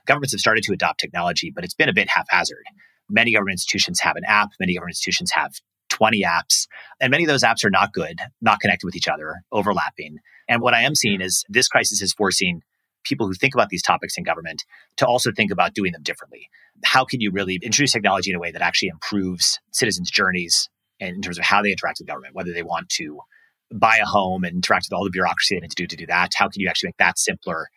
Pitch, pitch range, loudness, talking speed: 90 Hz, 90-100 Hz, -20 LUFS, 240 wpm